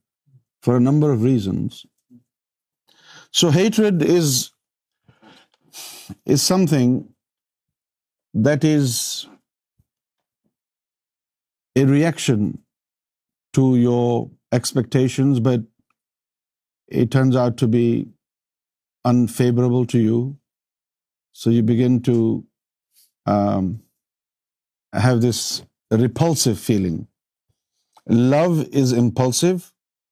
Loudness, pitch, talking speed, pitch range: -19 LUFS, 125 Hz, 70 wpm, 120-135 Hz